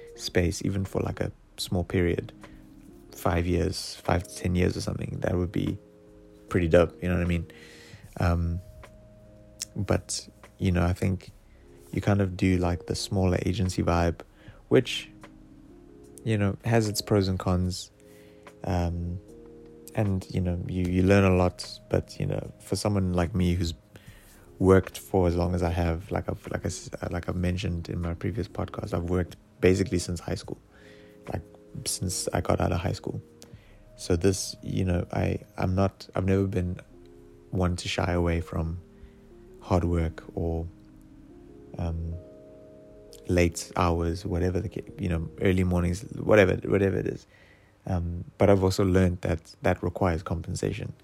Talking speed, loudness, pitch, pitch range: 160 wpm, -28 LUFS, 90 Hz, 85-100 Hz